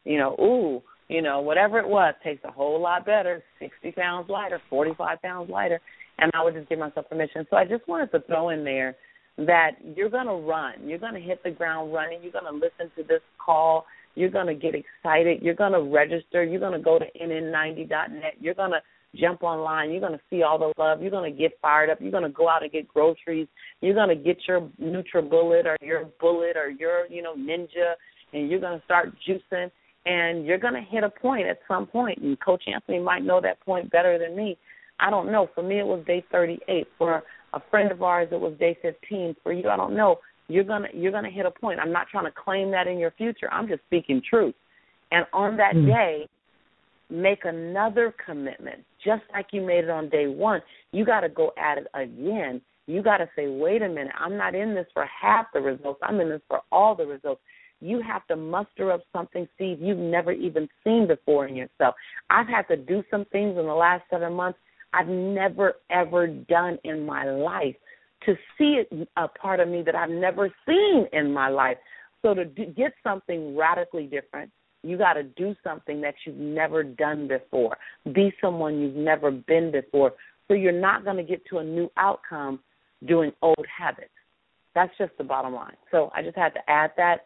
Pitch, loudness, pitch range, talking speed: 175 Hz, -25 LUFS, 160-195 Hz, 205 wpm